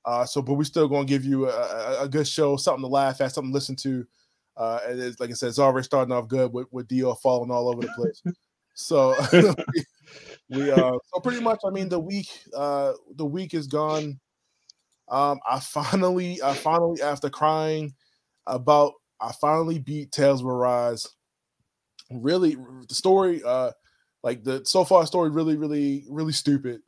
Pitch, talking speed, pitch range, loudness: 145 Hz, 185 wpm, 130-165 Hz, -24 LUFS